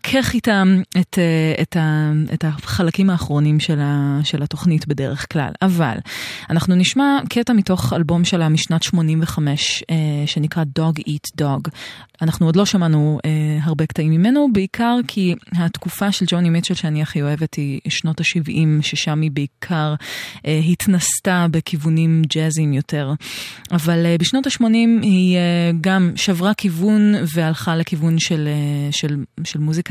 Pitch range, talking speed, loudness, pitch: 155-180 Hz, 125 wpm, -18 LUFS, 165 Hz